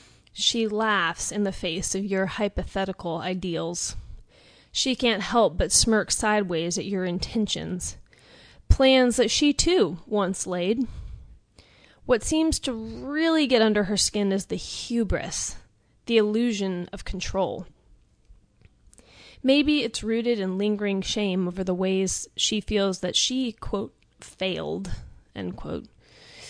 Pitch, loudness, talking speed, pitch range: 205 Hz, -25 LUFS, 125 wpm, 185-235 Hz